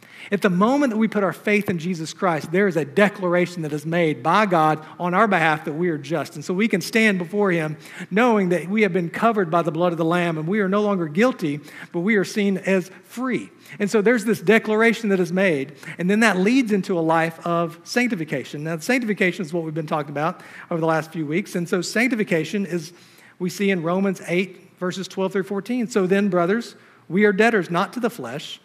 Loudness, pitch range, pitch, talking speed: -21 LUFS, 170-210 Hz, 185 Hz, 230 wpm